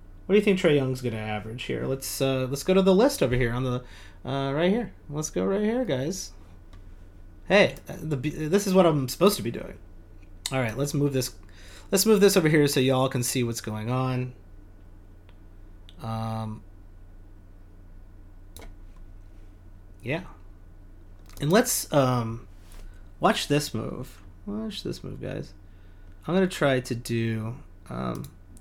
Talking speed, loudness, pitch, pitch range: 155 wpm, -25 LUFS, 110 Hz, 90-140 Hz